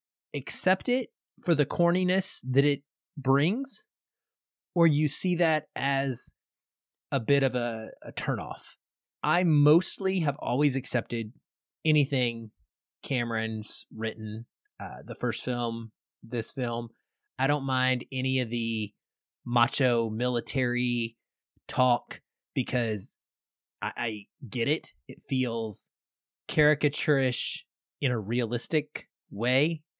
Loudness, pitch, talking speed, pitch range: -28 LUFS, 130 Hz, 110 wpm, 115-150 Hz